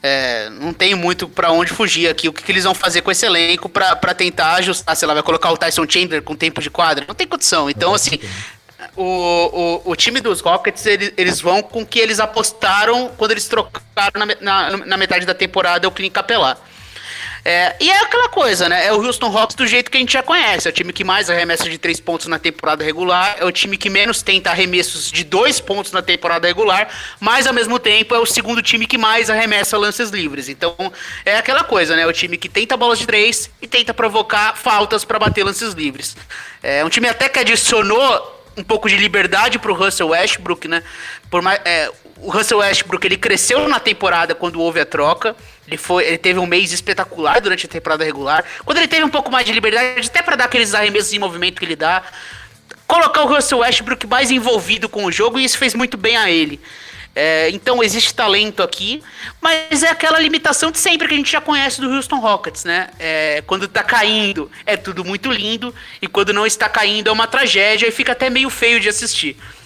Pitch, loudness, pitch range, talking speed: 205 Hz, -14 LUFS, 175-240 Hz, 220 wpm